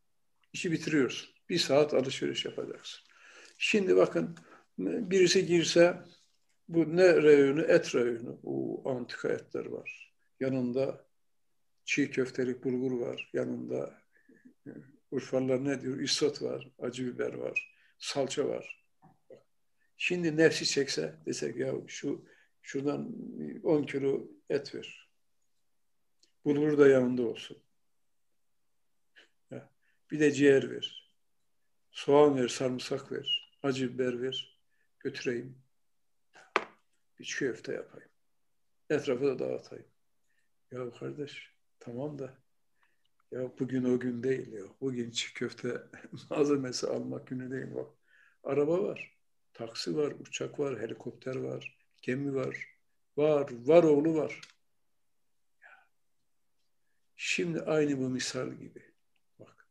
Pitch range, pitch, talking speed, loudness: 125-150 Hz, 135 Hz, 110 wpm, -31 LUFS